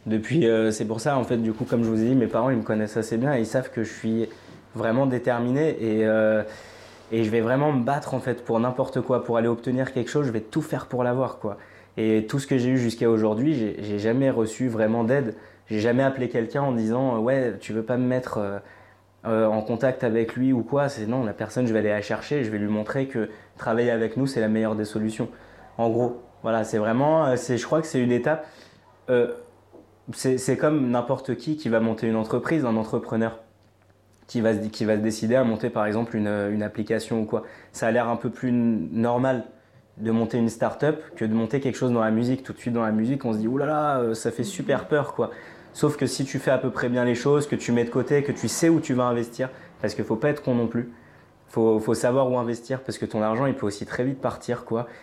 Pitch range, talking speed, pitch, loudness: 110-130 Hz, 255 wpm, 120 Hz, -24 LUFS